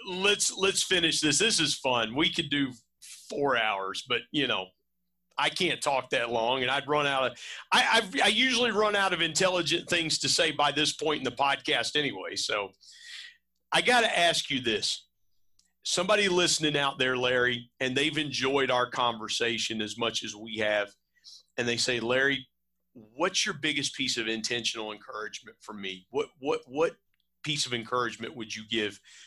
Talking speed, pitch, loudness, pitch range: 180 wpm, 135 Hz, -27 LUFS, 115-165 Hz